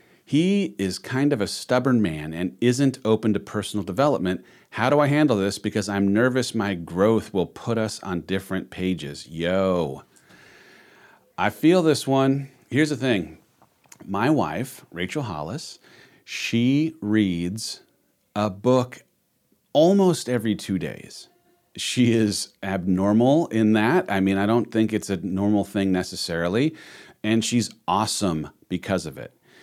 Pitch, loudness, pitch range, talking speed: 110 Hz, -23 LUFS, 95-125 Hz, 140 wpm